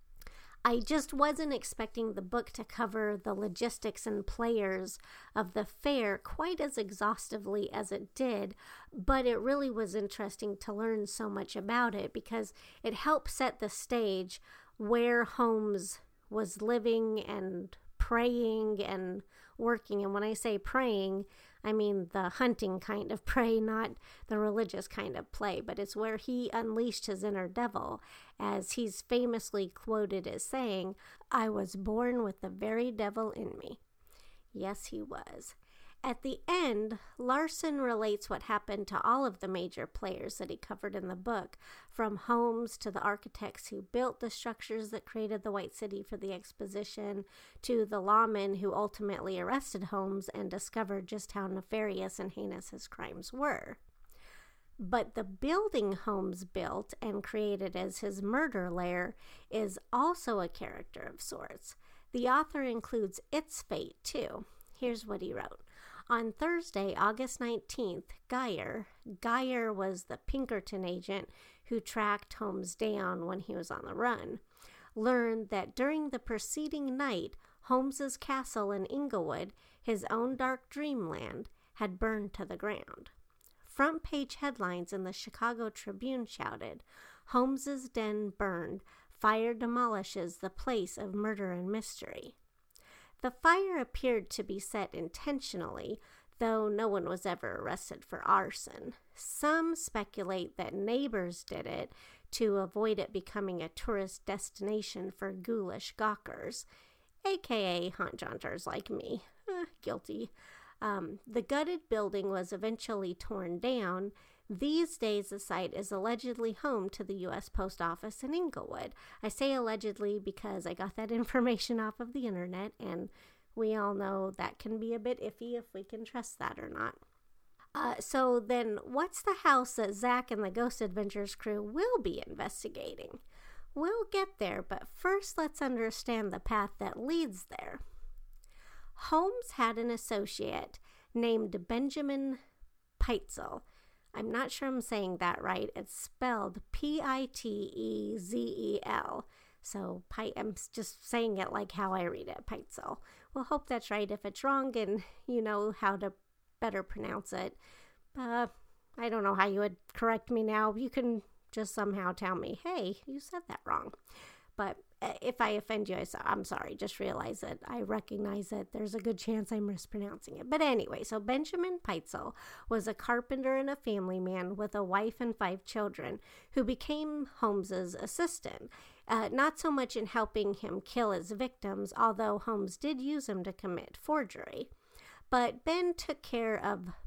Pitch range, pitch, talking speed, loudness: 200-250 Hz, 220 Hz, 155 wpm, -36 LUFS